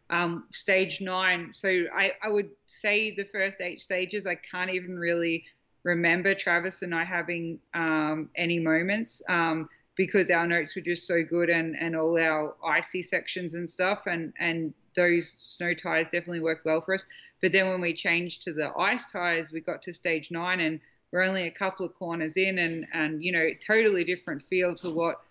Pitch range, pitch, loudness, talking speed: 165-185 Hz, 175 Hz, -27 LUFS, 190 wpm